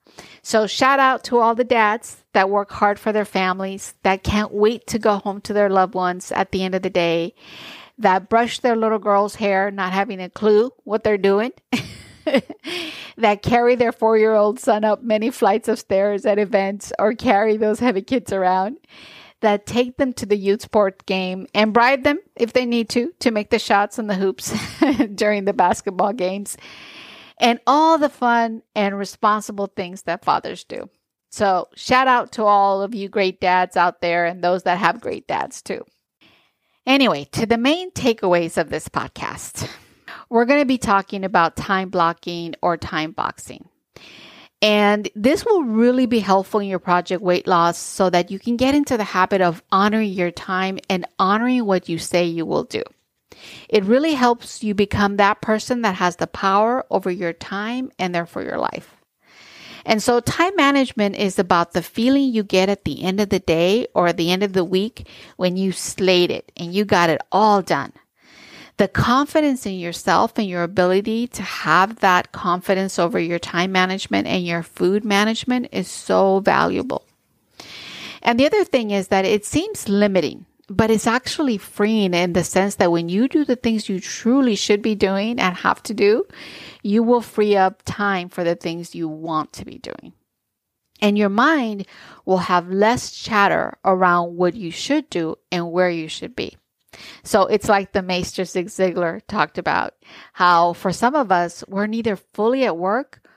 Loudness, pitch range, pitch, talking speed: -19 LUFS, 185-230 Hz, 205 Hz, 185 wpm